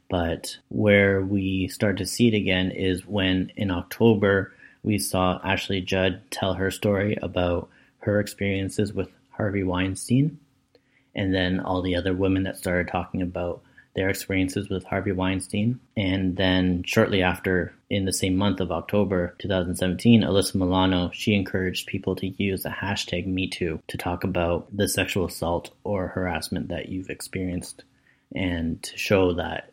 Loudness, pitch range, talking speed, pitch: -25 LUFS, 90-100 Hz, 155 wpm, 95 Hz